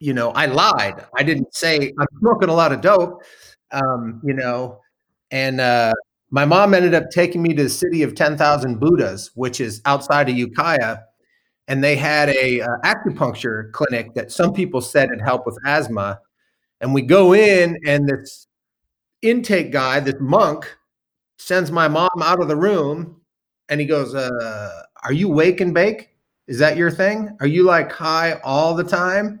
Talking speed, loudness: 180 wpm, -17 LUFS